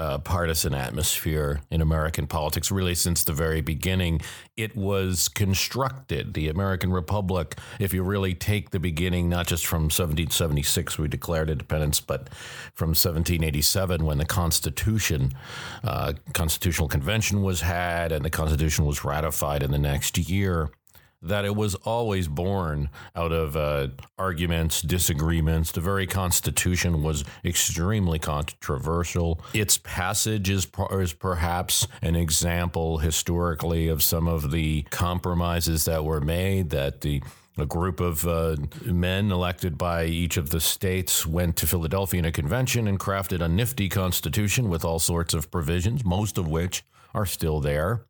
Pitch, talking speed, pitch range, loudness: 85 Hz, 145 wpm, 80-95 Hz, -25 LUFS